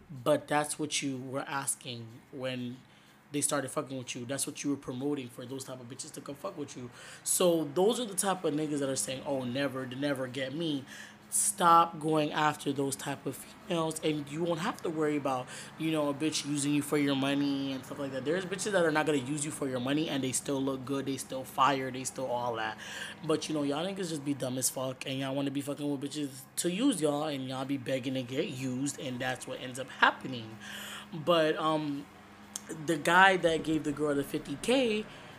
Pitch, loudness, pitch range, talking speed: 145 Hz, -31 LUFS, 130-155 Hz, 230 wpm